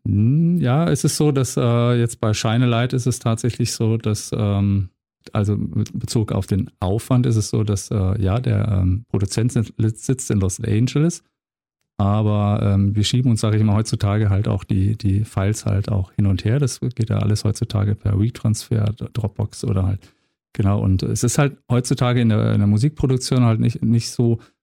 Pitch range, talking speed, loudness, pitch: 105-120 Hz, 190 wpm, -20 LUFS, 110 Hz